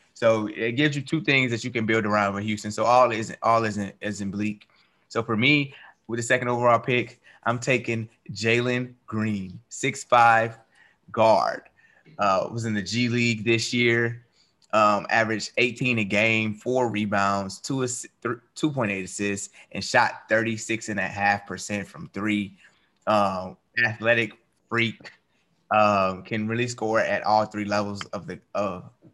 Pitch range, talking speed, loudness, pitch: 105-120 Hz, 170 wpm, -24 LUFS, 115 Hz